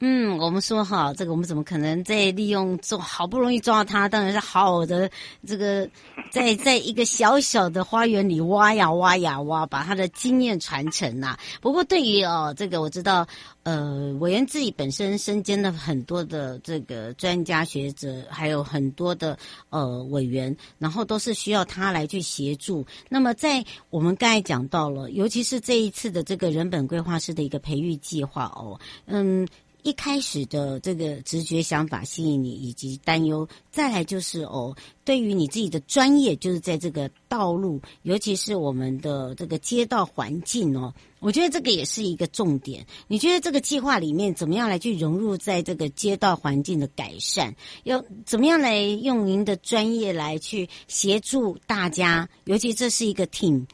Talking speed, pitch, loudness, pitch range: 275 characters per minute, 180 Hz, -24 LUFS, 150-215 Hz